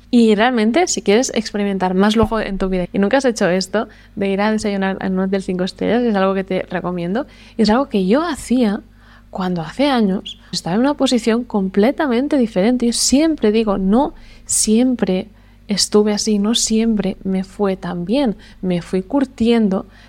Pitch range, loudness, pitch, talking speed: 190-240 Hz, -17 LUFS, 210 Hz, 175 wpm